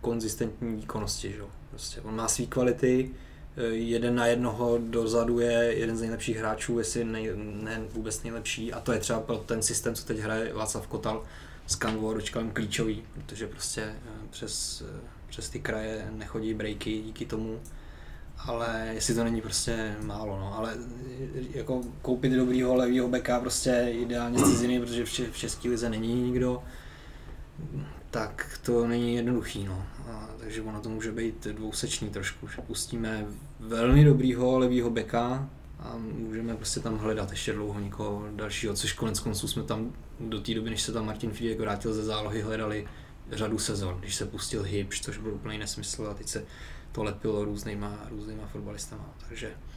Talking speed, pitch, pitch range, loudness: 160 wpm, 110 Hz, 105-120 Hz, -30 LUFS